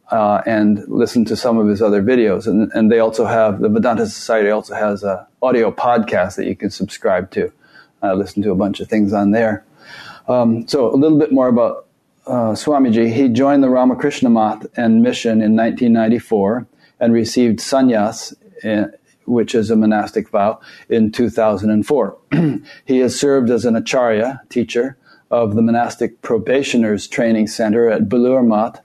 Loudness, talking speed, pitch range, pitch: -16 LUFS, 170 wpm, 105-125 Hz, 115 Hz